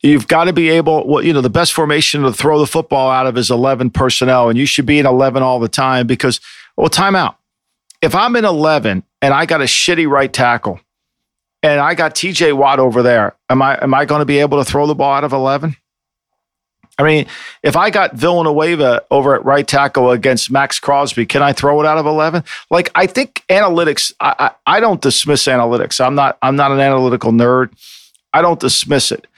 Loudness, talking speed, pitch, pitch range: -12 LUFS, 220 wpm, 140 Hz, 130-155 Hz